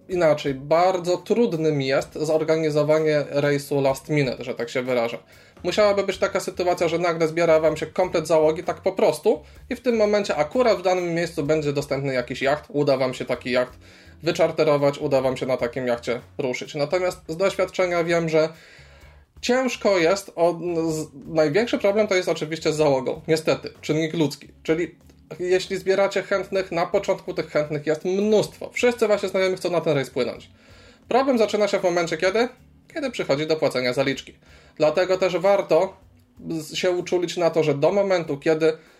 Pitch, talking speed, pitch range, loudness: 165 Hz, 170 wpm, 145-190 Hz, -22 LUFS